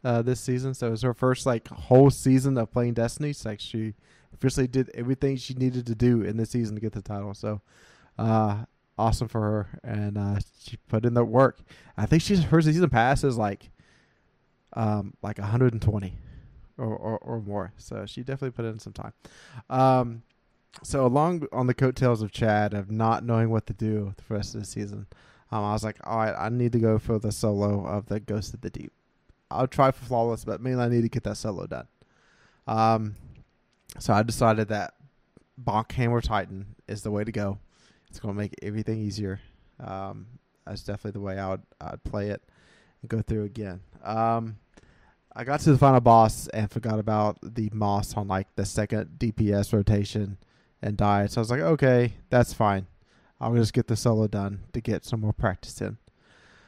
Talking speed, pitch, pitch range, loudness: 200 wpm, 110 Hz, 105-120 Hz, -26 LUFS